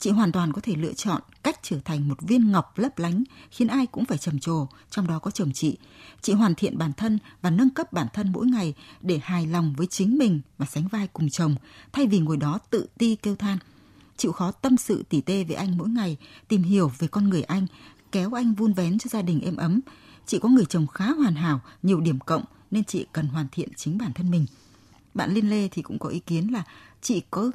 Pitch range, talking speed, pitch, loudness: 155-215 Hz, 245 wpm, 180 Hz, -25 LUFS